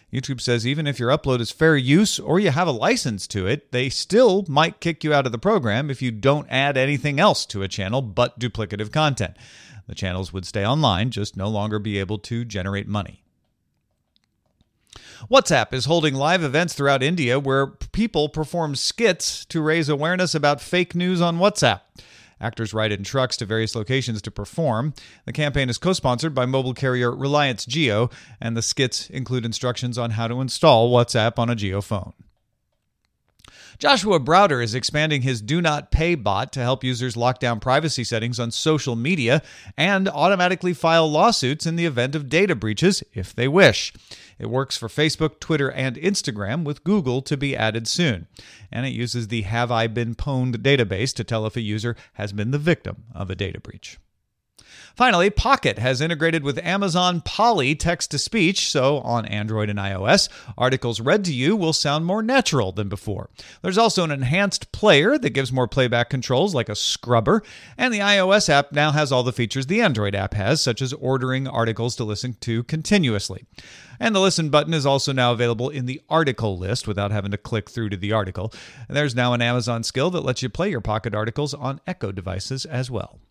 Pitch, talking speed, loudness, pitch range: 130 Hz, 190 wpm, -21 LUFS, 115-155 Hz